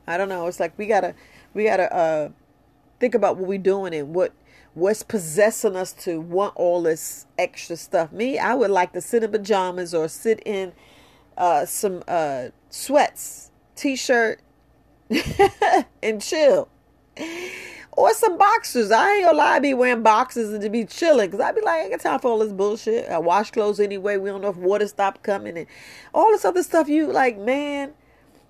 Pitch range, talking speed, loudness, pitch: 185-255 Hz, 190 wpm, -21 LUFS, 210 Hz